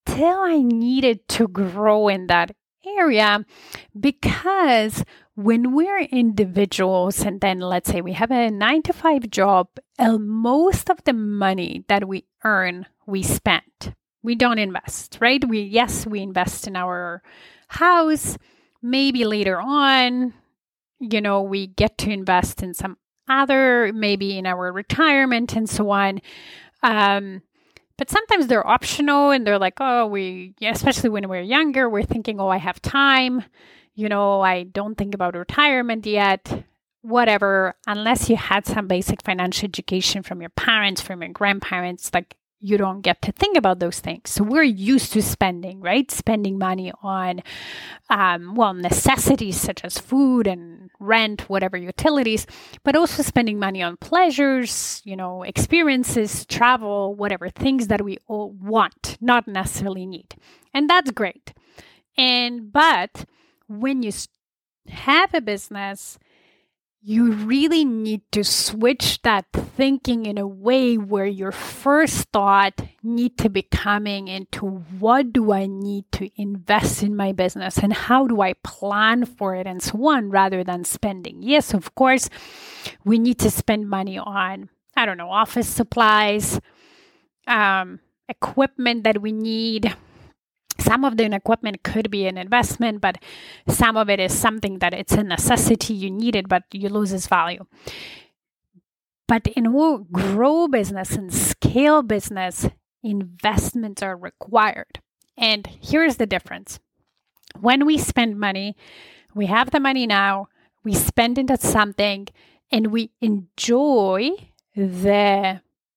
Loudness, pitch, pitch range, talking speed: -20 LUFS, 210 Hz, 195-245 Hz, 145 wpm